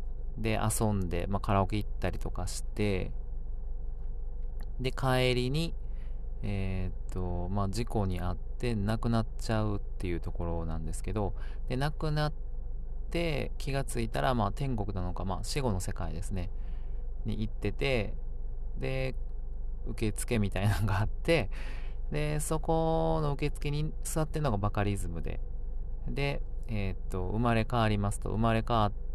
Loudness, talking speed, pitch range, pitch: -33 LUFS, 285 characters per minute, 95-125 Hz, 105 Hz